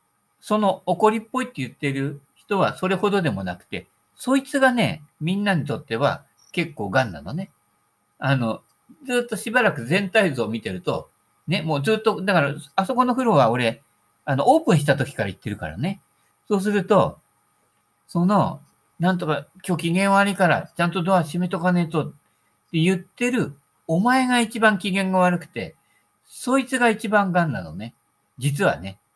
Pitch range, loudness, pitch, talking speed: 140-205 Hz, -22 LUFS, 180 Hz, 325 characters per minute